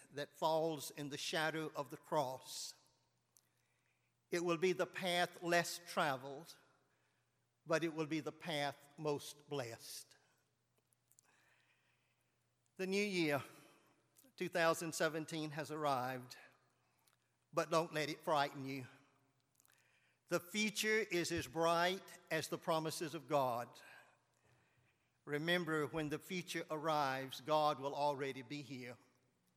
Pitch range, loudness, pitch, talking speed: 140-170 Hz, -40 LUFS, 155 Hz, 110 wpm